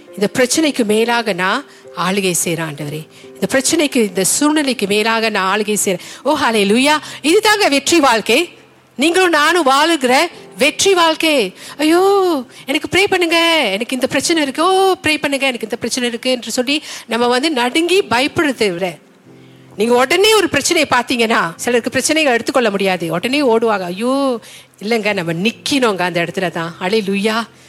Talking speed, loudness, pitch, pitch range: 140 wpm, -14 LUFS, 245 Hz, 205-305 Hz